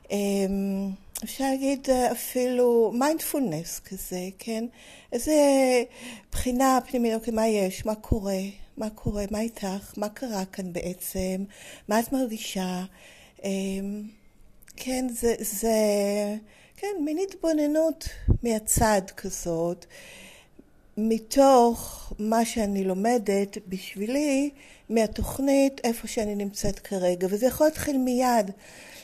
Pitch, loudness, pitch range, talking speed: 220 Hz, -26 LUFS, 200-255 Hz, 95 wpm